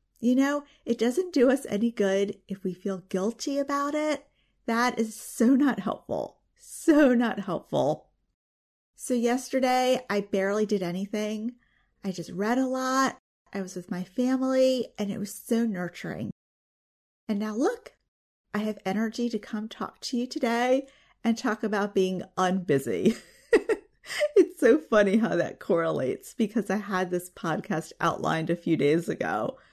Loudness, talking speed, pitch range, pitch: -27 LUFS, 155 wpm, 195-260 Hz, 220 Hz